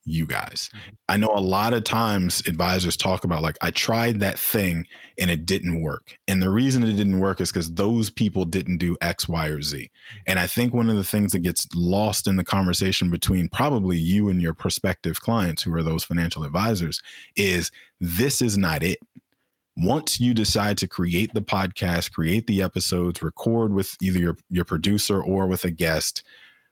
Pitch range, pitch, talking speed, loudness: 85-105 Hz, 95 Hz, 195 wpm, -23 LUFS